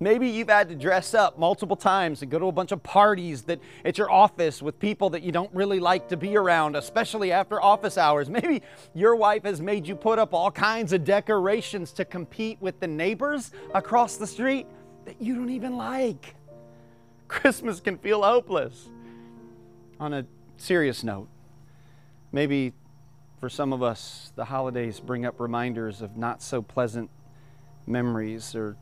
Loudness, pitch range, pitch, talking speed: -25 LUFS, 135-205 Hz, 170 Hz, 170 wpm